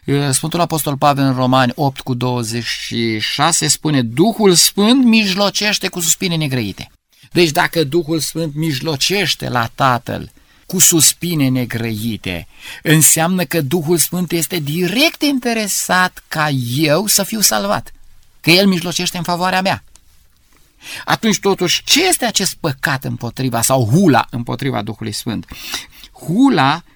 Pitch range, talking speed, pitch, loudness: 125-180 Hz, 125 wpm, 155 Hz, -15 LUFS